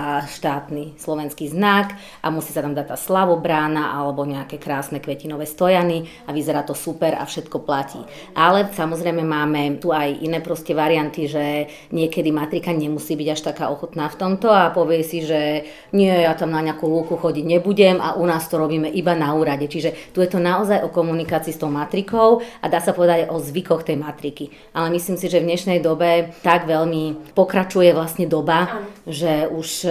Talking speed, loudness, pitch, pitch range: 190 wpm, -20 LUFS, 160 Hz, 150-175 Hz